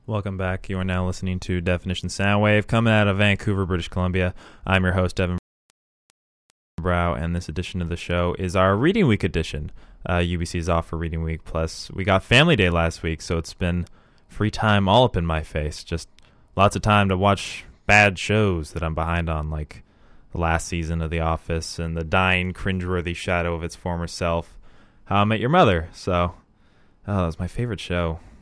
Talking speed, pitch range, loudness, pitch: 200 wpm, 85-100 Hz, -22 LUFS, 90 Hz